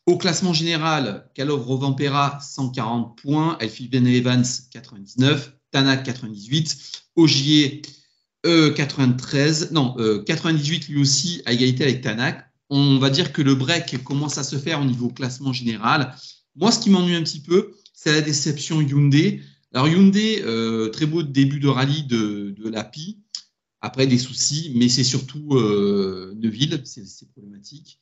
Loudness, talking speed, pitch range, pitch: -20 LUFS, 155 wpm, 125-155 Hz, 140 Hz